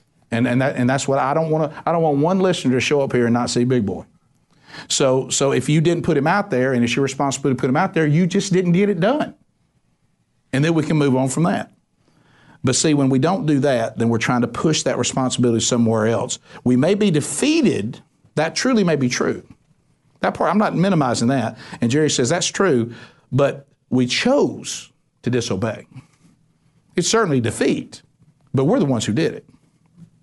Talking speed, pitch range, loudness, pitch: 210 wpm, 125-165 Hz, -19 LUFS, 140 Hz